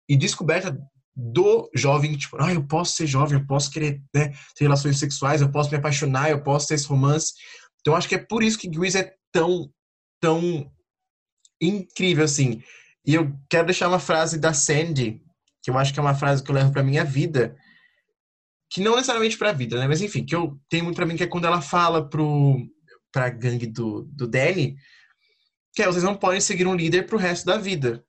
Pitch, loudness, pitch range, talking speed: 155 Hz, -22 LUFS, 140-180 Hz, 210 wpm